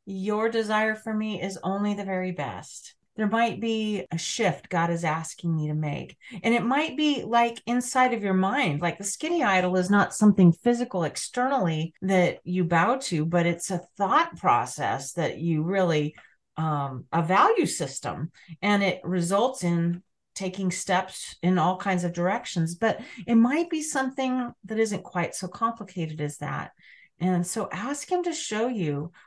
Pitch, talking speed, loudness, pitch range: 190 Hz, 170 wpm, -26 LUFS, 170-225 Hz